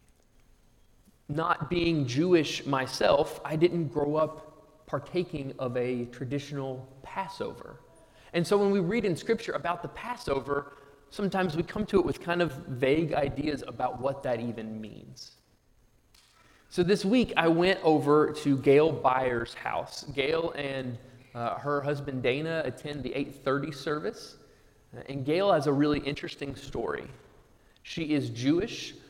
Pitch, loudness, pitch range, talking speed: 145 Hz, -29 LUFS, 135-170 Hz, 140 wpm